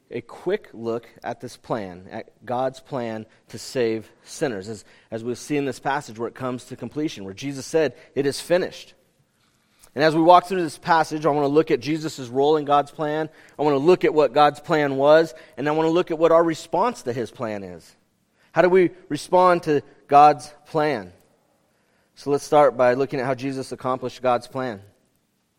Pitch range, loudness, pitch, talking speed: 120-155 Hz, -22 LUFS, 140 Hz, 205 wpm